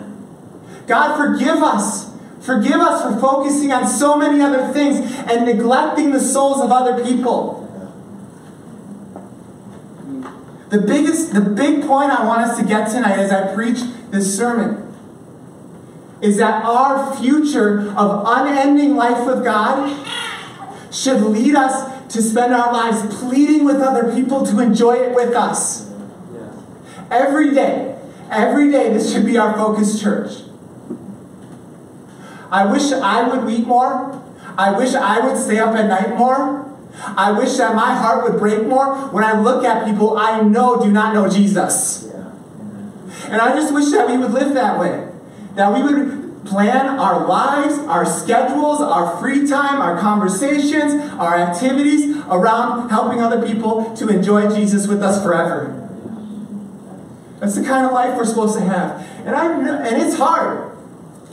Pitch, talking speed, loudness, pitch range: 240 Hz, 150 wpm, -16 LUFS, 215-270 Hz